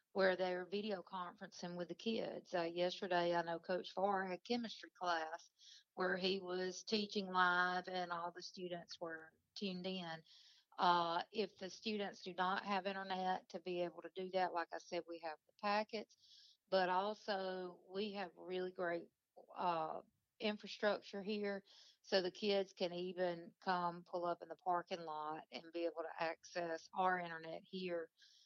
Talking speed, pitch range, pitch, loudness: 165 wpm, 175-195 Hz, 185 Hz, -42 LUFS